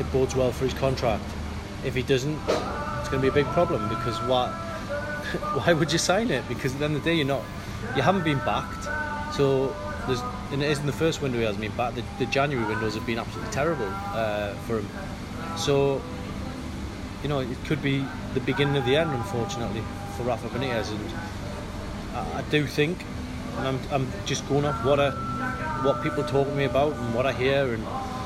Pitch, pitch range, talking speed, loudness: 125 Hz, 105-140 Hz, 200 wpm, -27 LUFS